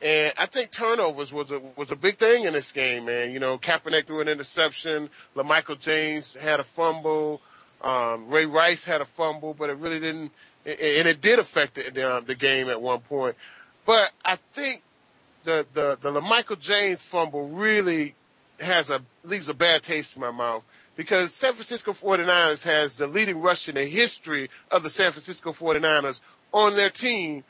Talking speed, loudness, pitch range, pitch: 180 wpm, -24 LUFS, 145-185 Hz, 155 Hz